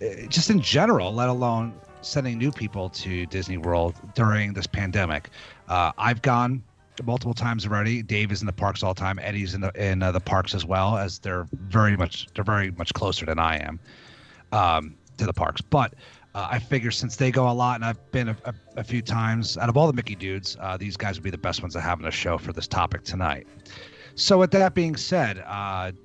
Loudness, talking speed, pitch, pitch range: -25 LUFS, 225 wpm, 105 Hz, 95-120 Hz